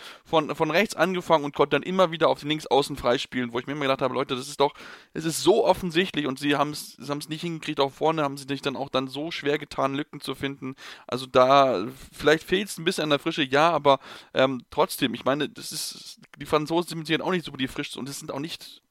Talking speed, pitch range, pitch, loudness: 260 wpm, 135-160 Hz, 145 Hz, -25 LUFS